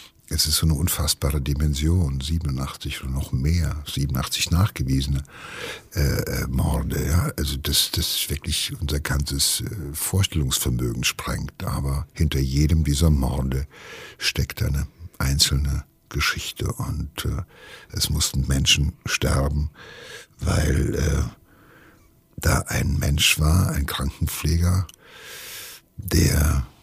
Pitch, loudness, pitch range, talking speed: 75 Hz, -23 LUFS, 70-80 Hz, 105 wpm